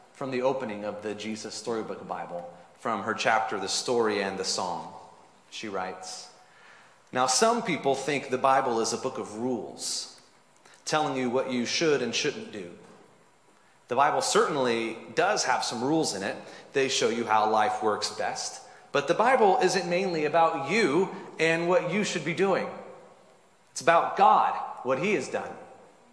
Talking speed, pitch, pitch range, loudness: 170 wpm, 130 Hz, 110-170 Hz, -27 LUFS